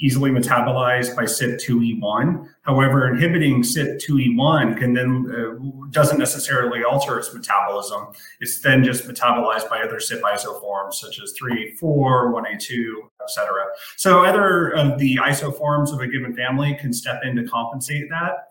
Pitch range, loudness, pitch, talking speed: 120-145 Hz, -20 LUFS, 125 Hz, 145 wpm